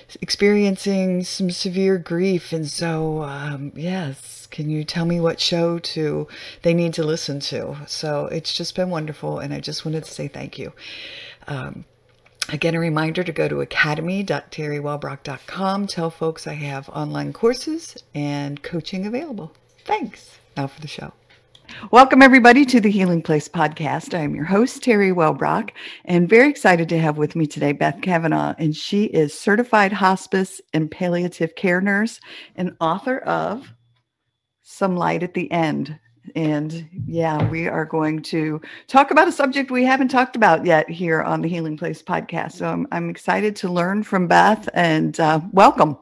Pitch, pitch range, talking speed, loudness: 165 Hz, 150-195 Hz, 165 wpm, -19 LUFS